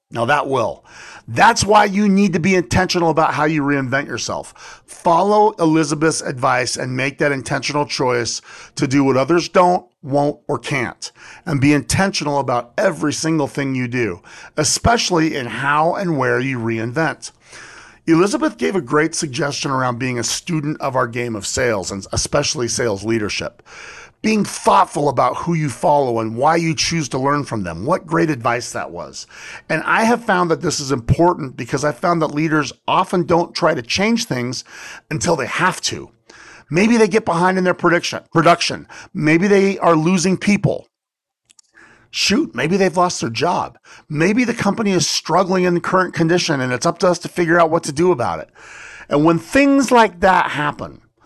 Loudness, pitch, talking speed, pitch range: -17 LUFS, 160 Hz, 180 wpm, 135-180 Hz